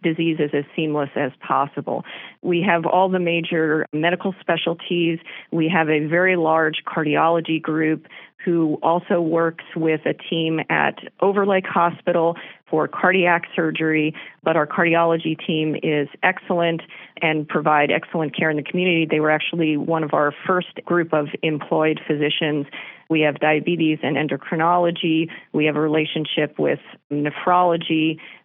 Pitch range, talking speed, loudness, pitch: 155-170 Hz, 140 wpm, -20 LUFS, 160 Hz